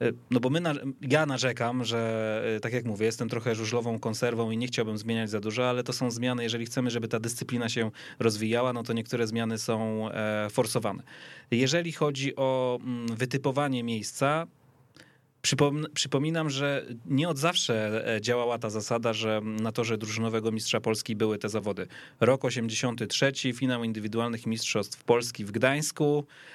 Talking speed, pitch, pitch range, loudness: 150 wpm, 120 Hz, 115-130 Hz, -29 LUFS